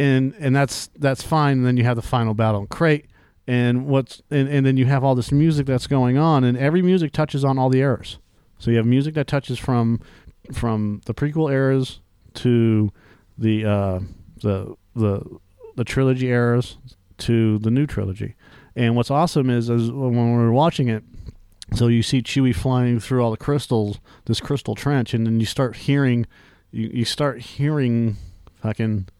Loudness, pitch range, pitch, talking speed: -20 LUFS, 110-135 Hz, 120 Hz, 185 wpm